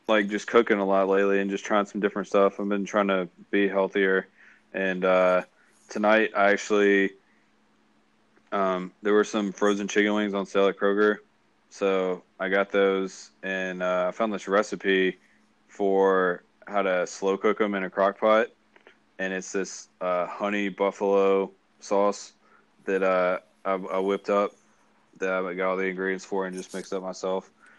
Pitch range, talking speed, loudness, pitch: 95-100 Hz, 170 wpm, -25 LUFS, 95 Hz